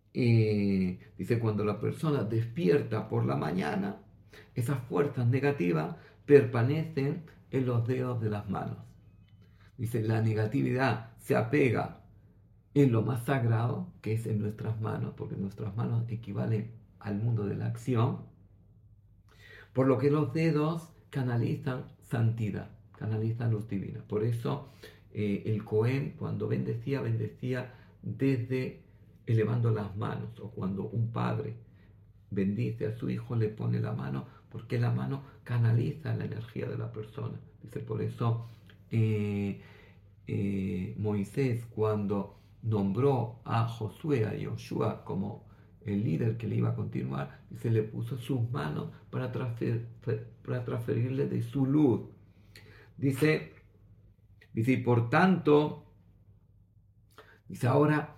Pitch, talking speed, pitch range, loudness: 110 Hz, 125 wpm, 105-125 Hz, -31 LUFS